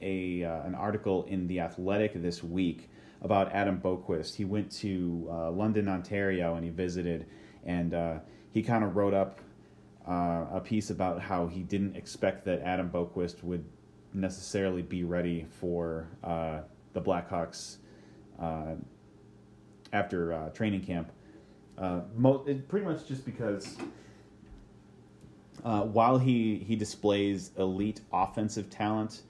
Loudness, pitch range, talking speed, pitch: -32 LUFS, 85-105 Hz, 135 wpm, 95 Hz